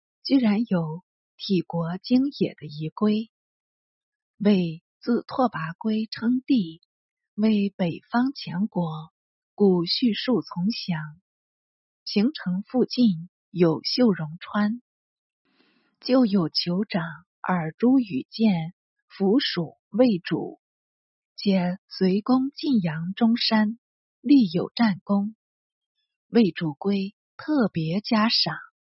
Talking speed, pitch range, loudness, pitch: 135 characters per minute, 175-245 Hz, -24 LUFS, 210 Hz